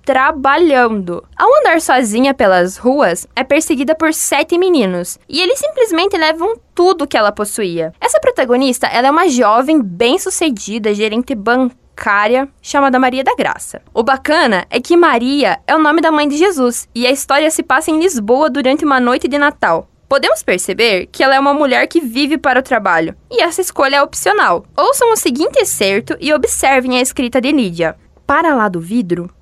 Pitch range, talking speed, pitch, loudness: 240-315 Hz, 175 wpm, 275 Hz, -13 LUFS